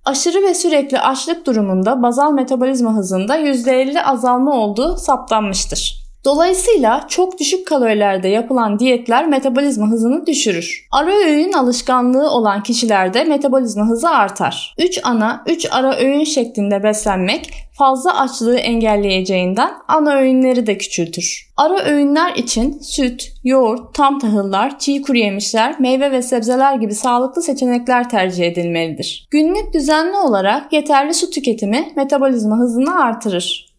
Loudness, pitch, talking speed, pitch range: -15 LUFS, 260 Hz, 125 wpm, 220-290 Hz